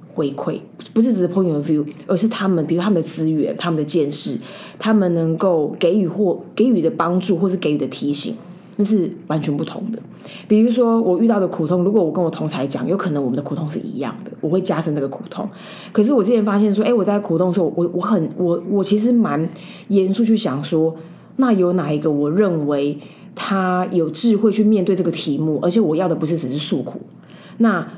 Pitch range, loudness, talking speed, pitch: 160-210 Hz, -18 LUFS, 335 characters per minute, 185 Hz